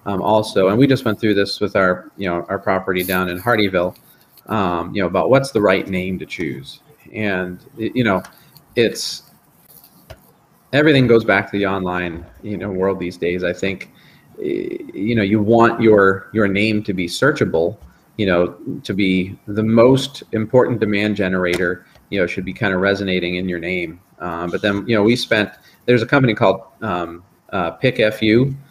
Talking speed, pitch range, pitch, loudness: 180 wpm, 90-115 Hz, 100 Hz, -18 LUFS